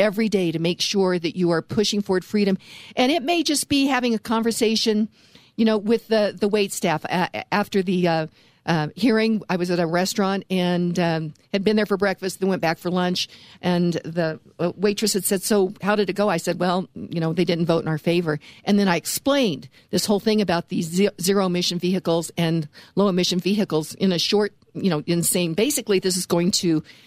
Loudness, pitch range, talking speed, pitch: -22 LUFS, 175-210 Hz, 215 wpm, 185 Hz